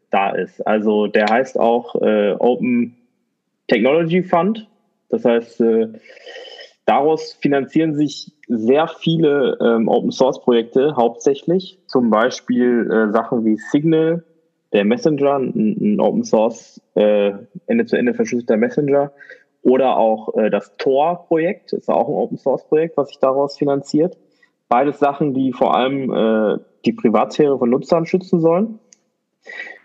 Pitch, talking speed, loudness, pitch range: 150 Hz, 140 wpm, -17 LUFS, 120-195 Hz